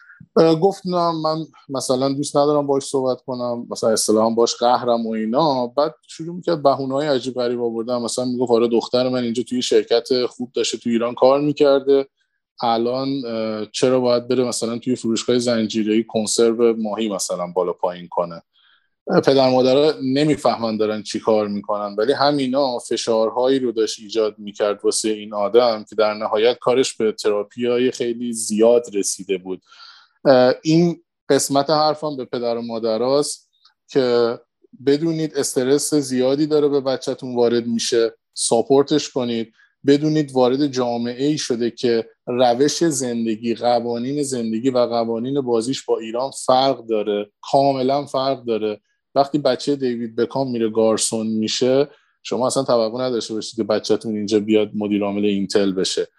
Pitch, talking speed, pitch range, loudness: 120 Hz, 145 wpm, 110-140 Hz, -19 LUFS